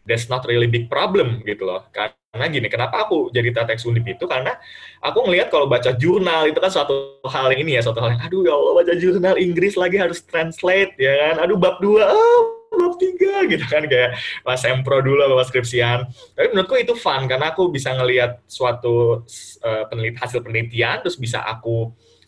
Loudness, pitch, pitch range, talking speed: -18 LUFS, 130 Hz, 120-185 Hz, 195 wpm